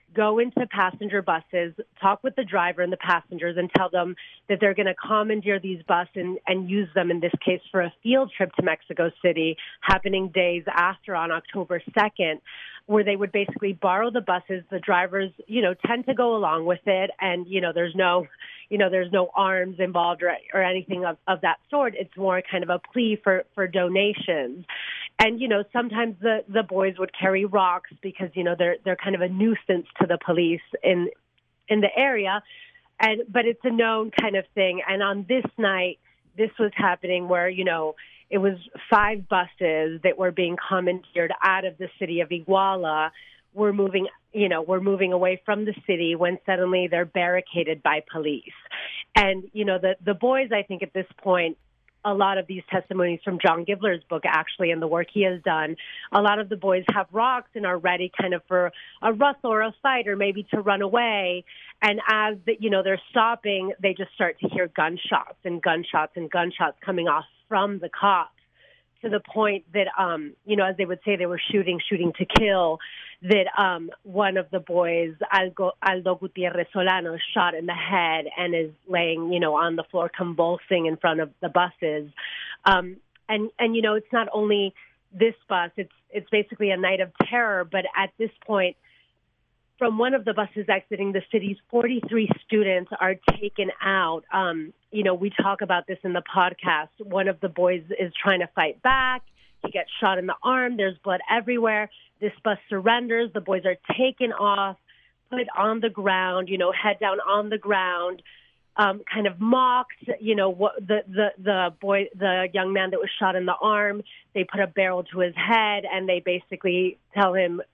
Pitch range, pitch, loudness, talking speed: 180-210 Hz, 190 Hz, -24 LUFS, 200 wpm